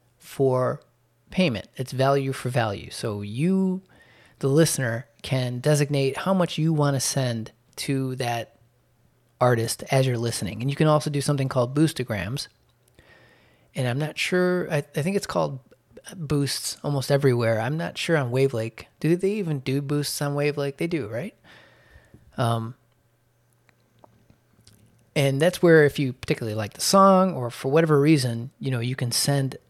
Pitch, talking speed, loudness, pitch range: 135 Hz, 160 wpm, -24 LUFS, 120-150 Hz